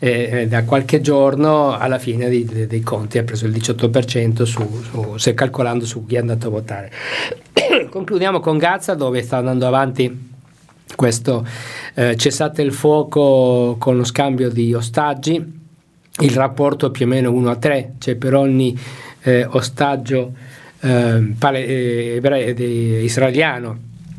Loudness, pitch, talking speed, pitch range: -17 LUFS, 130 Hz, 145 wpm, 120-145 Hz